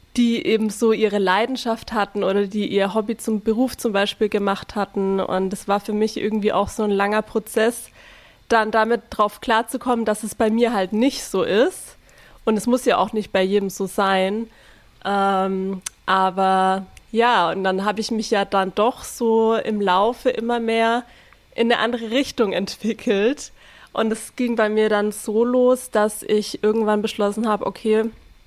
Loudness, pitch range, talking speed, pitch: -21 LUFS, 200-230 Hz, 175 wpm, 215 Hz